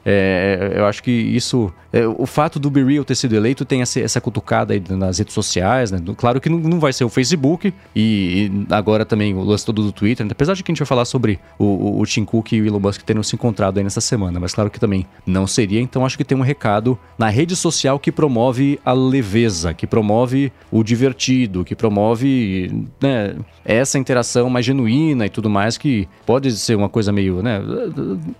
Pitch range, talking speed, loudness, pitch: 100-130 Hz, 220 wpm, -17 LUFS, 115 Hz